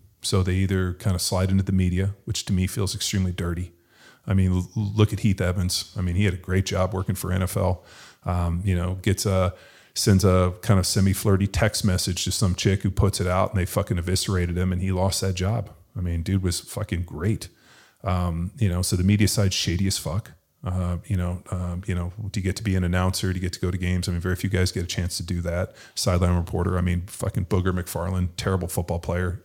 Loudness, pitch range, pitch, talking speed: -24 LUFS, 90-100 Hz, 95 Hz, 240 wpm